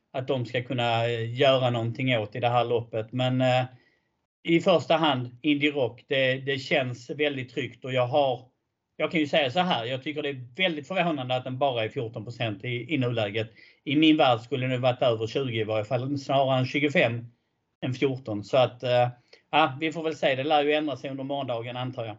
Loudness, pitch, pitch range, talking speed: -26 LUFS, 130 Hz, 120-145 Hz, 210 wpm